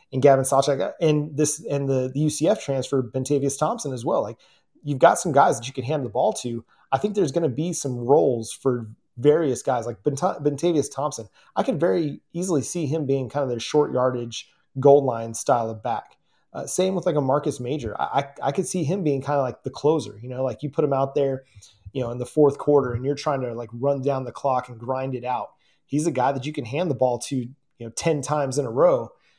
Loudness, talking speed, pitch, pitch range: -23 LUFS, 245 wpm, 140 Hz, 125-150 Hz